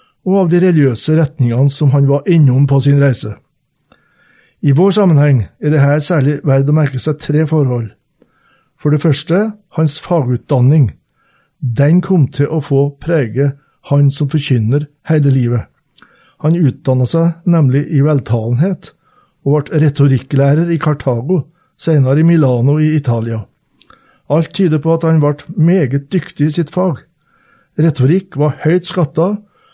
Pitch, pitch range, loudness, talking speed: 150 Hz, 140-165 Hz, -13 LUFS, 145 wpm